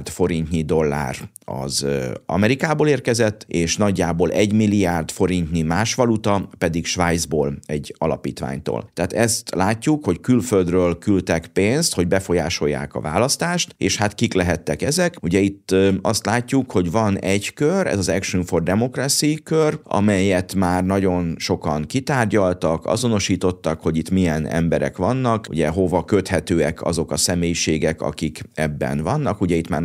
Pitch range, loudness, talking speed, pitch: 85-110 Hz, -20 LUFS, 140 wpm, 95 Hz